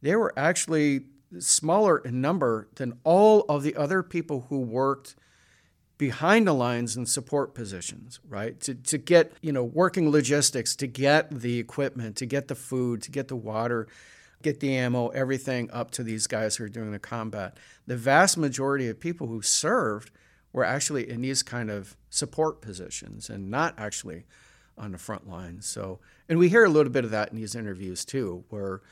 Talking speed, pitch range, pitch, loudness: 185 wpm, 110-145 Hz, 125 Hz, -26 LUFS